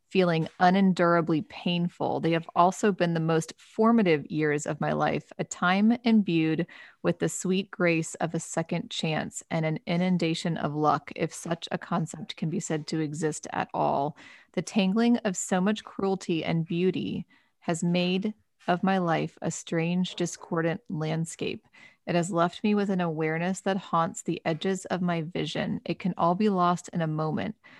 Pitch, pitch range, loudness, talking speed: 175 Hz, 165-190 Hz, -28 LUFS, 175 wpm